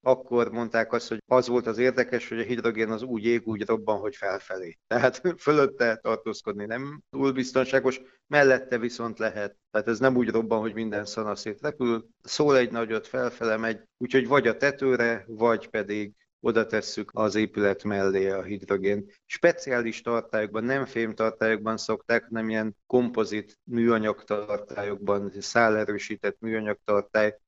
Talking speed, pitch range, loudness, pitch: 150 wpm, 105-125 Hz, -26 LUFS, 115 Hz